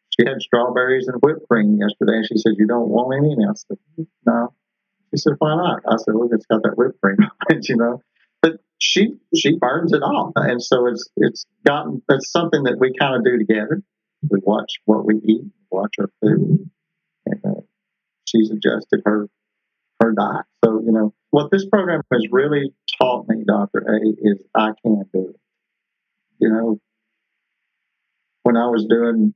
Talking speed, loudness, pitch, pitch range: 180 wpm, -18 LUFS, 120 Hz, 110-155 Hz